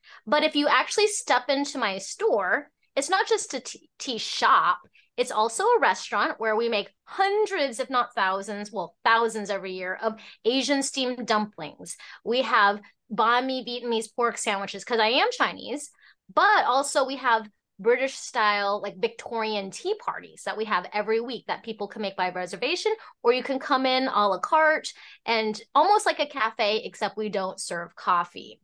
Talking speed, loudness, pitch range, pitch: 175 wpm, -25 LUFS, 210-280 Hz, 230 Hz